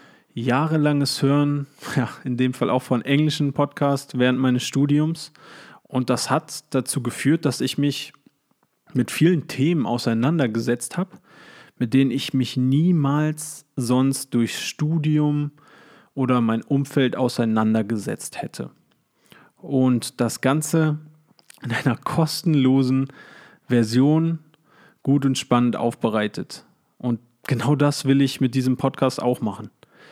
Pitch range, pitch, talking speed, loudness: 125-150 Hz, 135 Hz, 120 wpm, -22 LUFS